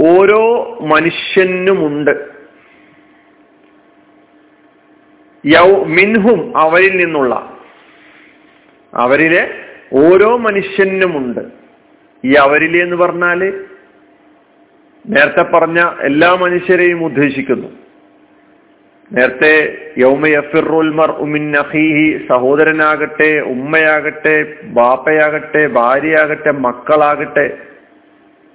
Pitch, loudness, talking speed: 170 Hz, -11 LUFS, 55 wpm